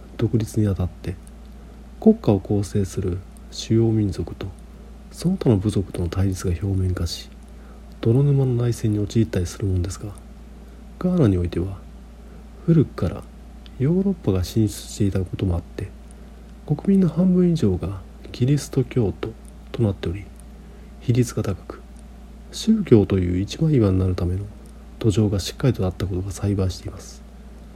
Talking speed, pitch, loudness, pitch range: 305 characters per minute, 100 Hz, -22 LUFS, 95-120 Hz